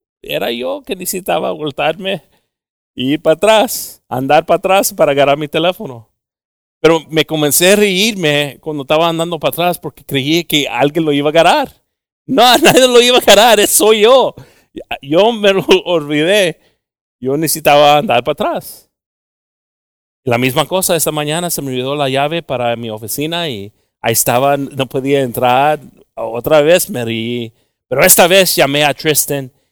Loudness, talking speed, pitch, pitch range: -12 LUFS, 165 wpm, 150 Hz, 135-175 Hz